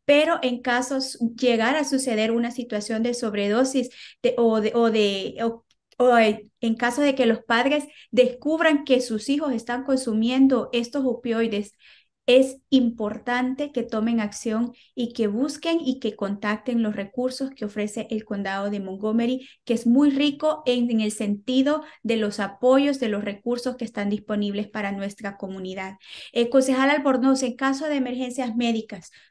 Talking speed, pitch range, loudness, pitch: 160 wpm, 215-260 Hz, -23 LUFS, 240 Hz